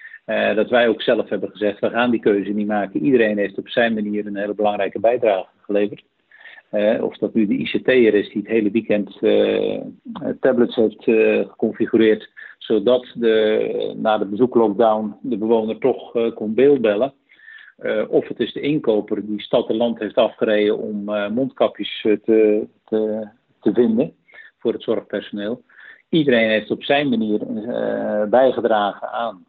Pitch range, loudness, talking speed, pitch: 105-130 Hz, -19 LUFS, 165 wpm, 110 Hz